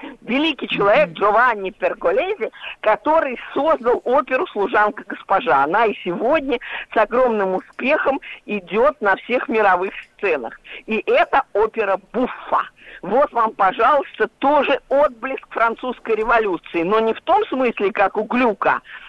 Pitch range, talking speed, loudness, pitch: 210-290 Hz, 125 wpm, -19 LUFS, 235 Hz